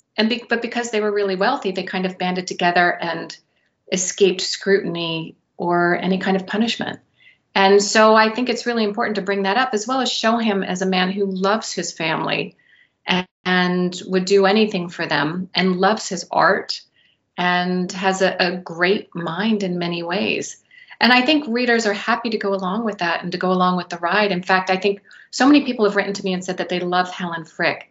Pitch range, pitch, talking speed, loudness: 180-215 Hz, 190 Hz, 215 wpm, -19 LUFS